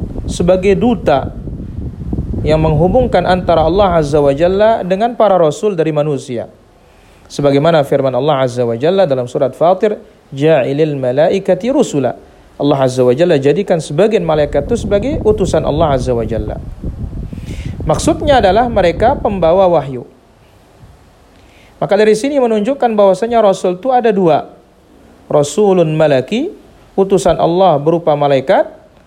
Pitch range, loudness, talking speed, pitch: 145-210 Hz, -12 LUFS, 125 wpm, 170 Hz